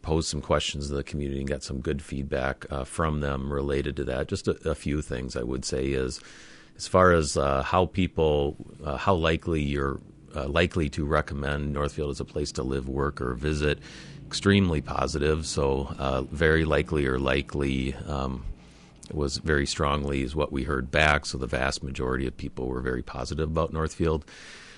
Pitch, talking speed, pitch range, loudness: 70 Hz, 185 wpm, 70-80 Hz, -27 LUFS